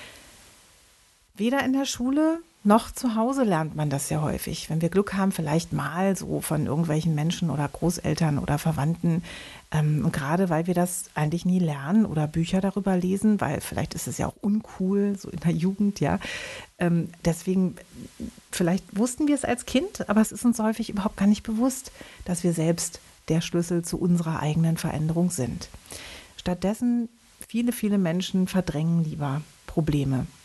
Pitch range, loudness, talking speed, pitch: 165-210 Hz, -26 LUFS, 165 wpm, 180 Hz